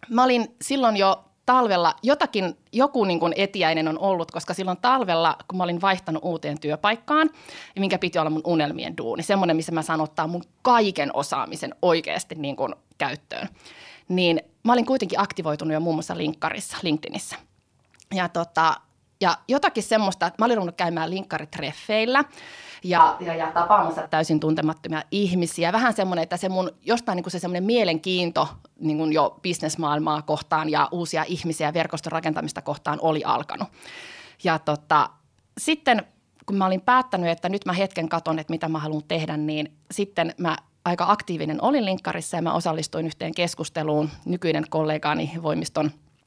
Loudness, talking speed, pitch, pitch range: -24 LUFS, 160 wpm, 170 Hz, 160-195 Hz